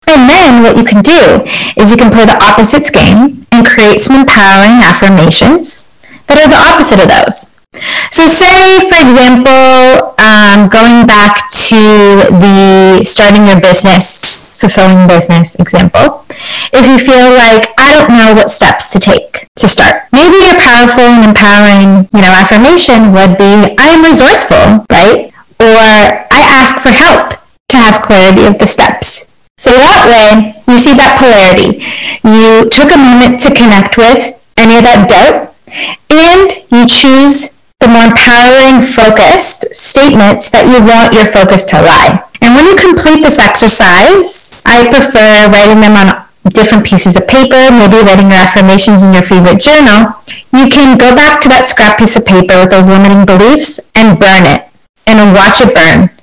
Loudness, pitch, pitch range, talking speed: -2 LUFS, 230 Hz, 205-265 Hz, 165 wpm